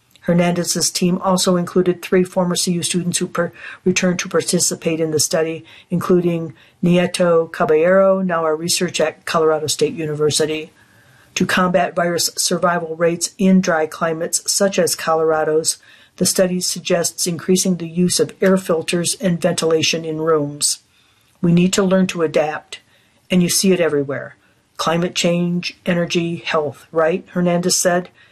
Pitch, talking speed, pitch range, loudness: 175 Hz, 145 wpm, 160-180 Hz, -17 LUFS